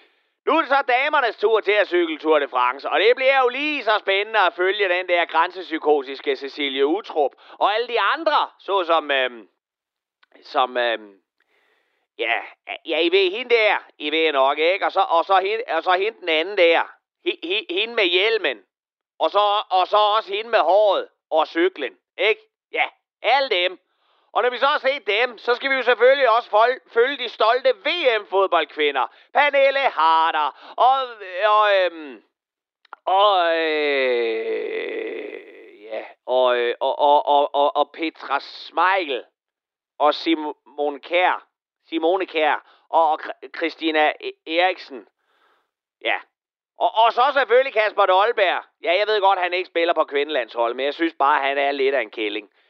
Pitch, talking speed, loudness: 195 Hz, 155 wpm, -20 LUFS